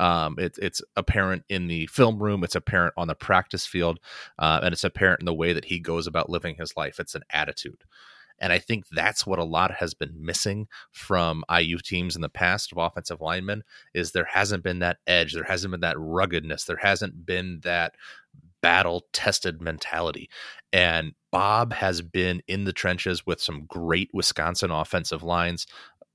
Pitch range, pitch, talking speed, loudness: 85-95 Hz, 85 Hz, 185 wpm, -25 LUFS